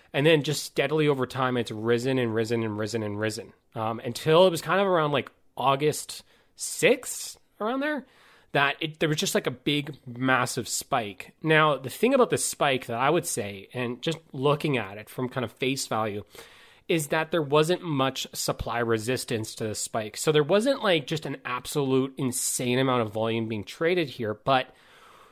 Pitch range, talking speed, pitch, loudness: 120-155 Hz, 190 wpm, 135 Hz, -26 LUFS